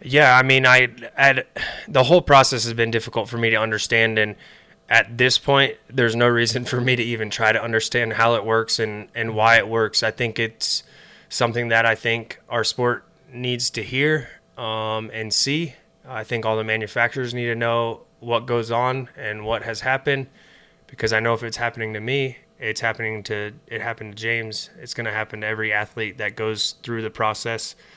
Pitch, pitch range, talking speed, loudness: 115 Hz, 110-125 Hz, 205 wpm, -20 LUFS